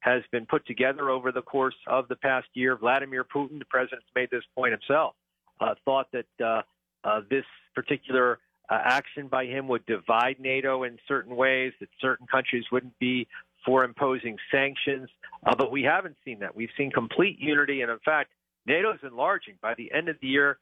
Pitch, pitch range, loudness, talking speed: 130 Hz, 125-135 Hz, -27 LUFS, 190 wpm